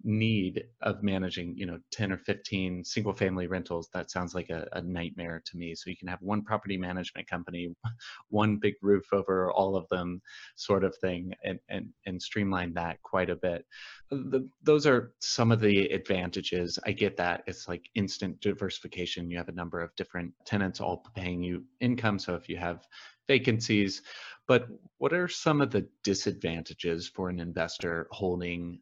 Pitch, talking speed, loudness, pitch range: 95 Hz, 180 wpm, -31 LUFS, 90-105 Hz